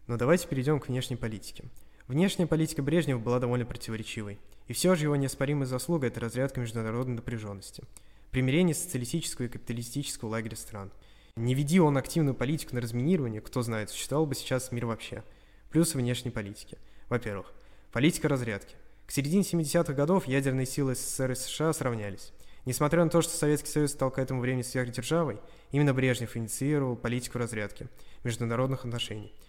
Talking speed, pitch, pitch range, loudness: 155 wpm, 125 Hz, 115-145 Hz, -30 LUFS